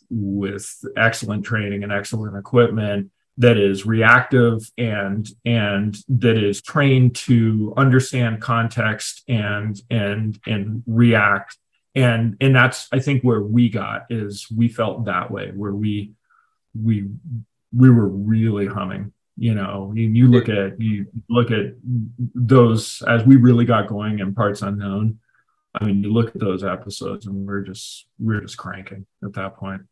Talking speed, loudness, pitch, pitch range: 150 wpm, -19 LUFS, 110 Hz, 100-120 Hz